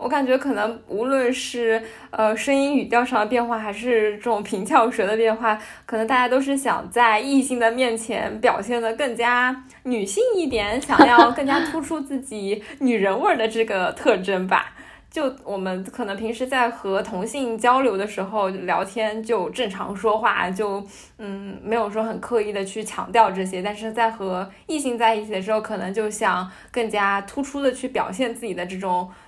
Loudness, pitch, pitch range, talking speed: -22 LUFS, 225 Hz, 205-250 Hz, 275 characters per minute